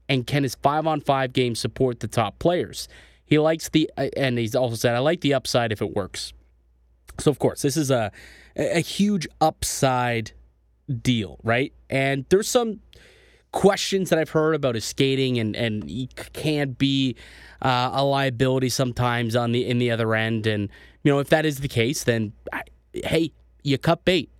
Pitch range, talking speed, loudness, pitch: 115-150 Hz, 180 wpm, -23 LUFS, 130 Hz